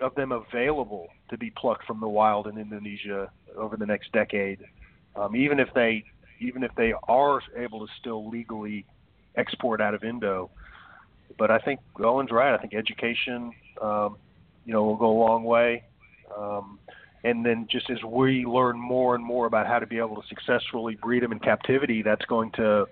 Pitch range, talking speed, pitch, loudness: 105-120 Hz, 185 wpm, 115 Hz, -26 LUFS